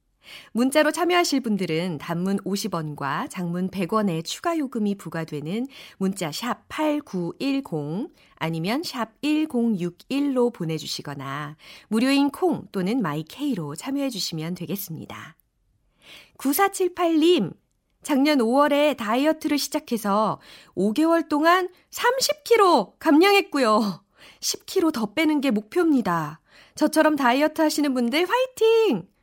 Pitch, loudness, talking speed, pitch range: 250 Hz, -23 LUFS, 235 characters per minute, 185-305 Hz